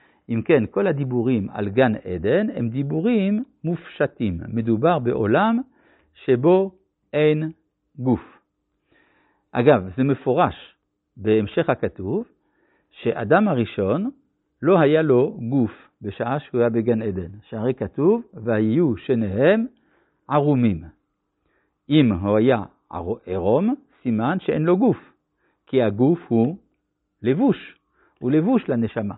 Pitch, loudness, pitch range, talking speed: 130 Hz, -21 LUFS, 115-180 Hz, 105 wpm